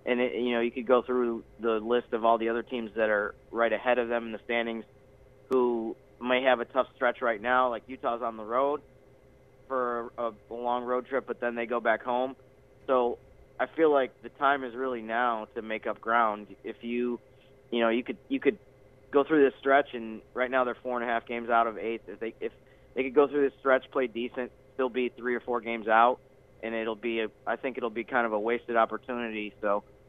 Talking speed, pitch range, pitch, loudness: 235 wpm, 115-130 Hz, 120 Hz, -29 LUFS